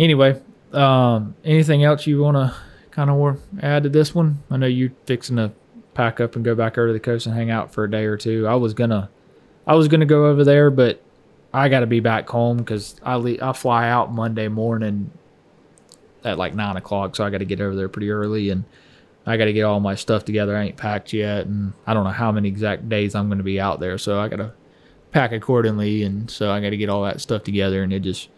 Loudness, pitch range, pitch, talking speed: -20 LUFS, 105-130 Hz, 110 Hz, 235 wpm